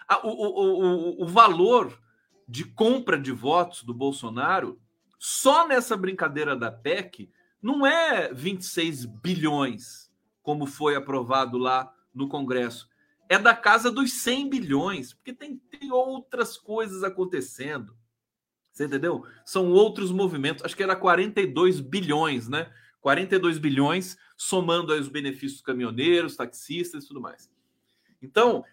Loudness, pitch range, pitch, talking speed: -24 LUFS, 135-205 Hz, 175 Hz, 130 wpm